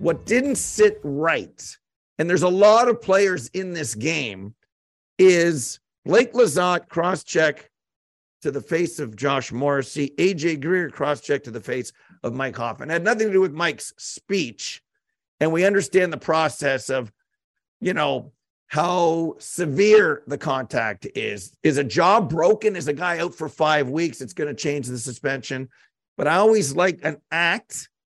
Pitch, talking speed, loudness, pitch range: 160 Hz, 160 wpm, -21 LUFS, 140-185 Hz